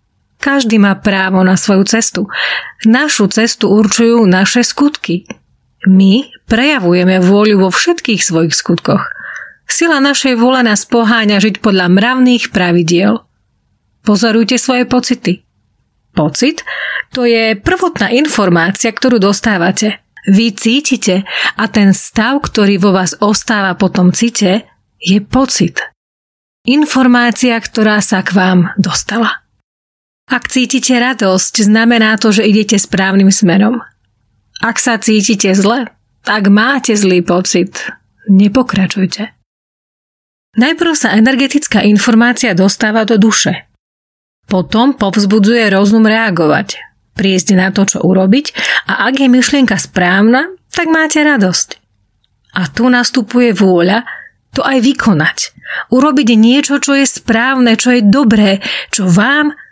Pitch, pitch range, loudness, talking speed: 220 Hz, 190-245 Hz, -10 LUFS, 115 wpm